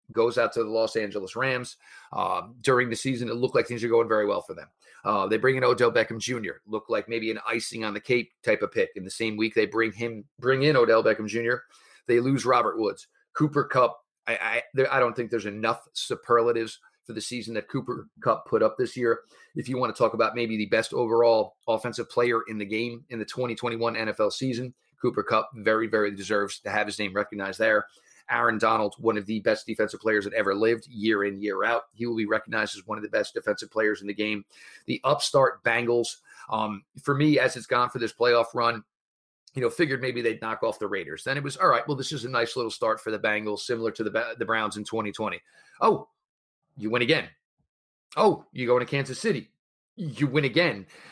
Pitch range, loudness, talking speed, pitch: 110-125 Hz, -26 LUFS, 225 wpm, 115 Hz